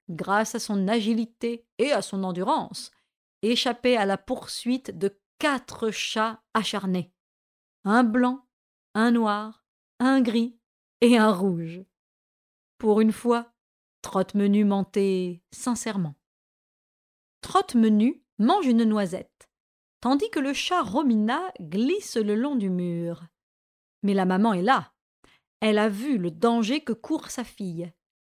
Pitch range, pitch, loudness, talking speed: 195-245 Hz, 220 Hz, -25 LUFS, 125 wpm